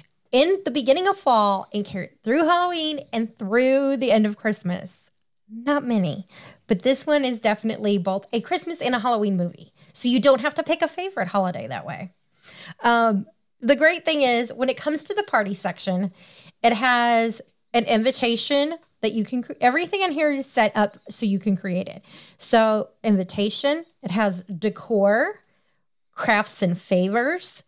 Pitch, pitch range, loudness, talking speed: 230 Hz, 200-275 Hz, -22 LUFS, 165 wpm